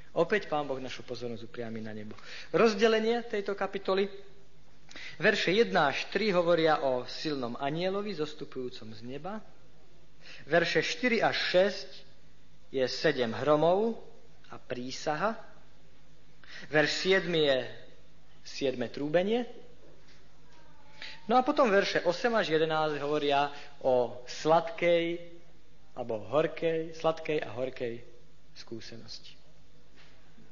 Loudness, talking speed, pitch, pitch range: -29 LUFS, 100 wpm, 155 Hz, 130-190 Hz